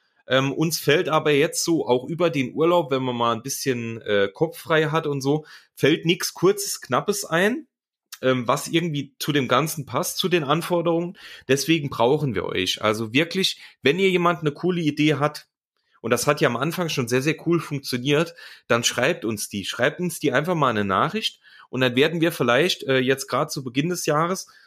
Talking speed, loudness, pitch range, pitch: 200 wpm, -22 LUFS, 130-170 Hz, 150 Hz